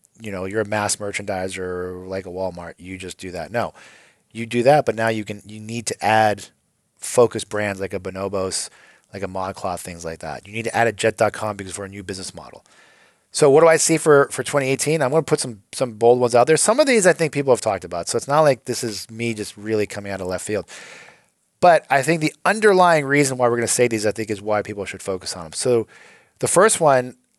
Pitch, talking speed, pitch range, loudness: 110 Hz, 250 wpm, 100-130 Hz, -19 LUFS